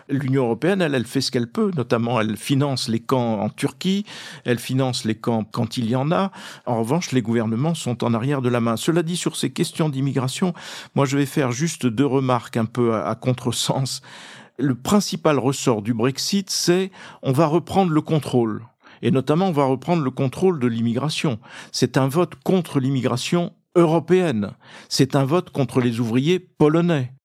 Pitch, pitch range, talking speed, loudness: 135 Hz, 125-170 Hz, 180 wpm, -21 LUFS